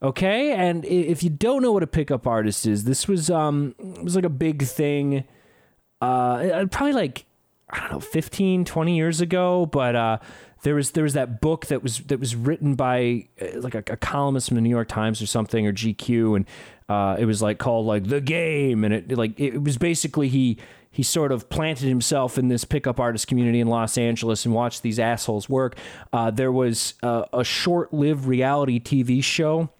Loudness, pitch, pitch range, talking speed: -23 LUFS, 130 Hz, 115-155 Hz, 205 wpm